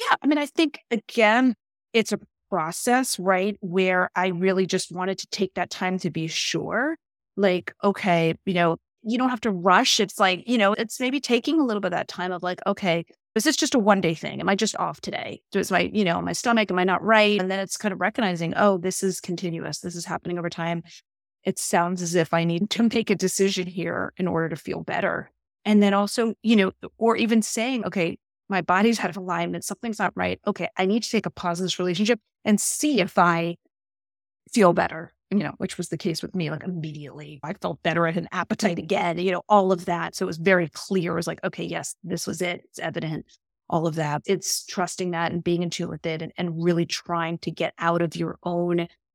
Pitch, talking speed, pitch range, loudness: 185 Hz, 235 wpm, 170-210 Hz, -24 LUFS